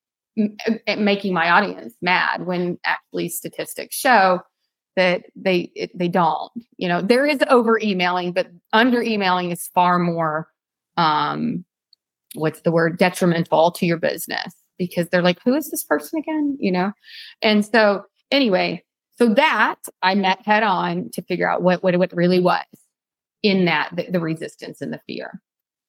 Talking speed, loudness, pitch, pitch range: 160 wpm, -20 LUFS, 185 Hz, 175-225 Hz